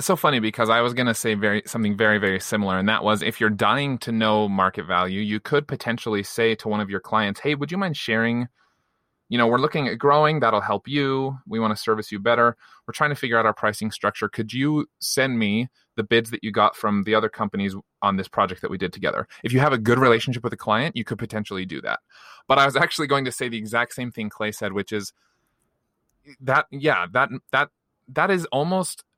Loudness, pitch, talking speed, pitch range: -22 LUFS, 115 Hz, 235 wpm, 105-135 Hz